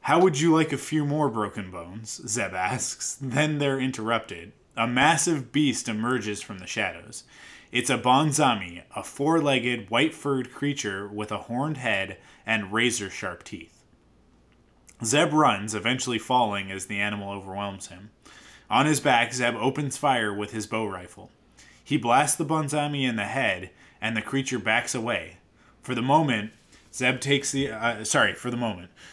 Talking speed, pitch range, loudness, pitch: 160 wpm, 105-135 Hz, -25 LUFS, 120 Hz